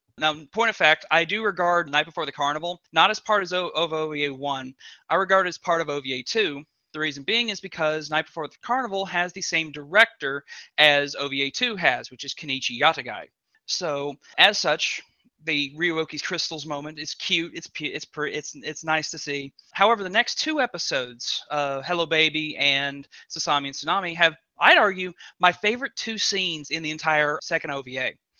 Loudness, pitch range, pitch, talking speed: -23 LUFS, 145-180 Hz, 160 Hz, 185 wpm